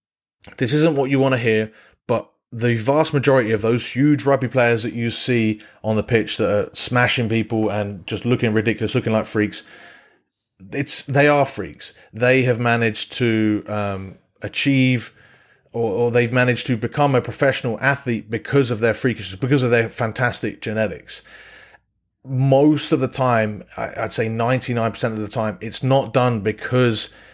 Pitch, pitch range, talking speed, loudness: 120 Hz, 110-130 Hz, 165 wpm, -19 LUFS